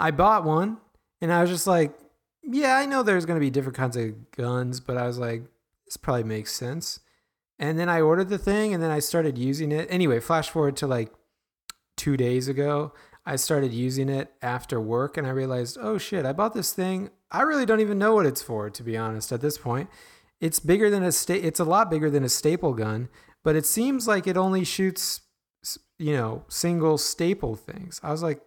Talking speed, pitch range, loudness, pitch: 215 wpm, 125-180 Hz, -25 LUFS, 155 Hz